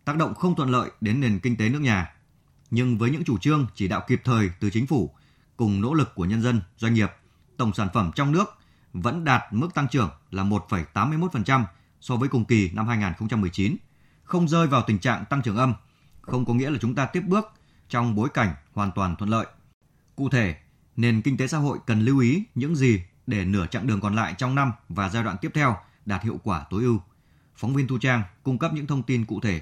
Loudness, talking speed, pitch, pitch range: -25 LUFS, 230 wpm, 115 Hz, 105-135 Hz